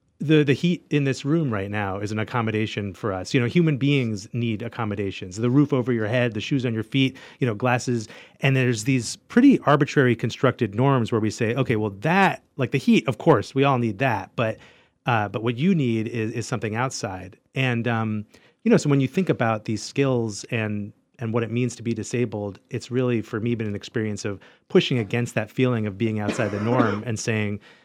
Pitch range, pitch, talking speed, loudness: 110-130 Hz, 120 Hz, 220 wpm, -23 LUFS